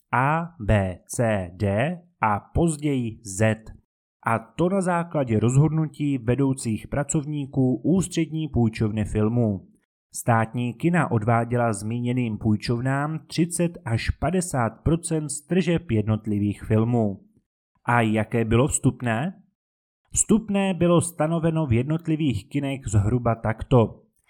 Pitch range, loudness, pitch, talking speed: 110-160 Hz, -24 LUFS, 125 Hz, 100 wpm